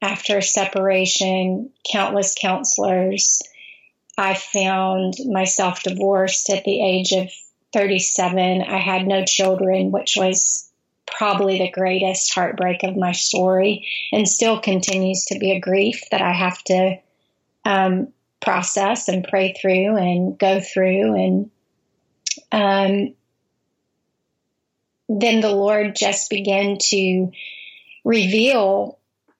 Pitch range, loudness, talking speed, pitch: 185-200 Hz, -19 LUFS, 110 wpm, 190 Hz